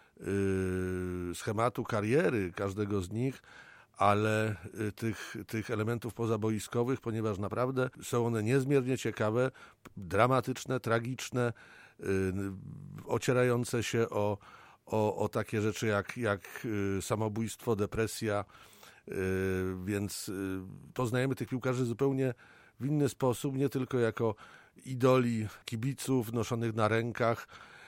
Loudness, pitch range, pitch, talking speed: -33 LUFS, 105-125 Hz, 115 Hz, 95 wpm